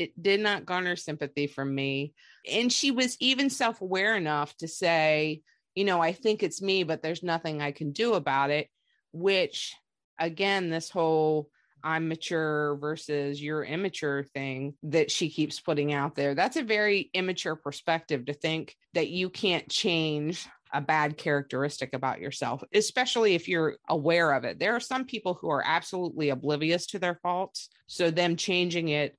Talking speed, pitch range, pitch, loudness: 170 wpm, 150-185 Hz, 165 Hz, -28 LUFS